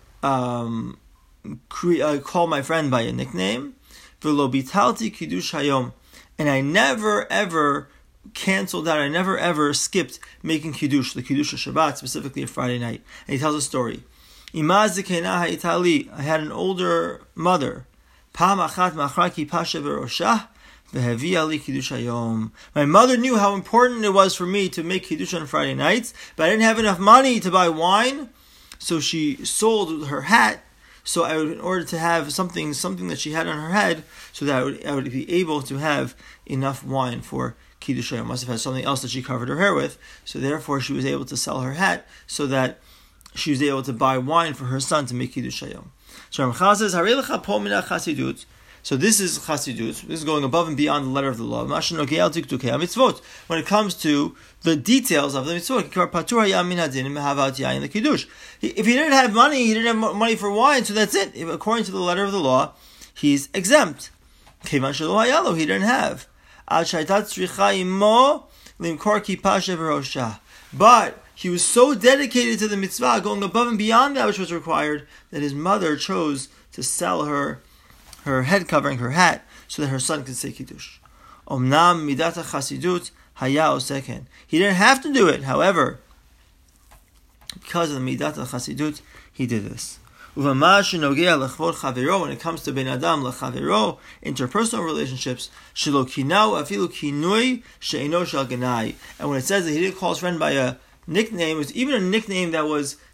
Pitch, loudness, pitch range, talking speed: 160 Hz, -21 LUFS, 135-195 Hz, 165 wpm